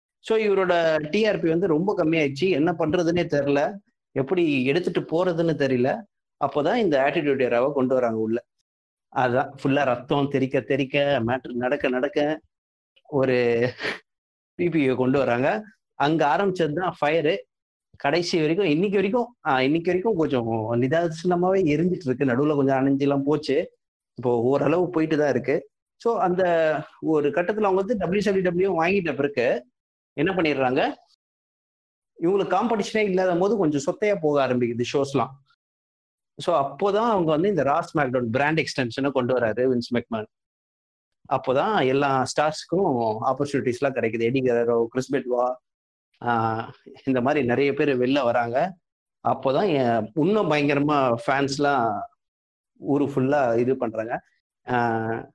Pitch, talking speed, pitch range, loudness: 145 Hz, 120 wpm, 125-175 Hz, -23 LUFS